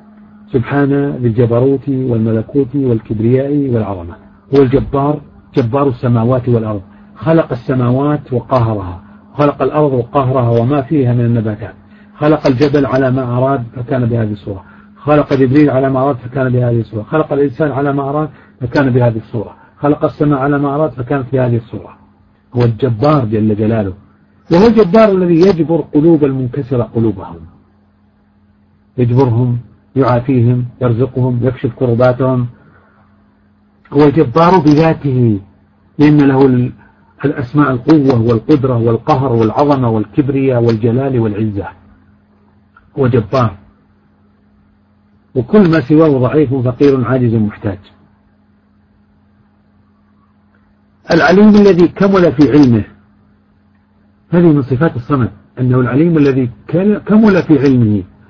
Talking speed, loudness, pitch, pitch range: 110 wpm, -12 LUFS, 125 Hz, 105-145 Hz